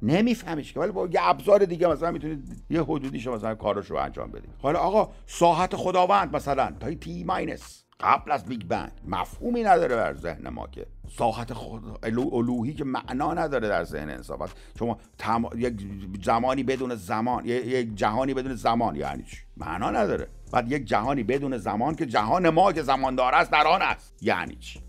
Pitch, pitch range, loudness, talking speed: 125 Hz, 115-160 Hz, -26 LUFS, 185 wpm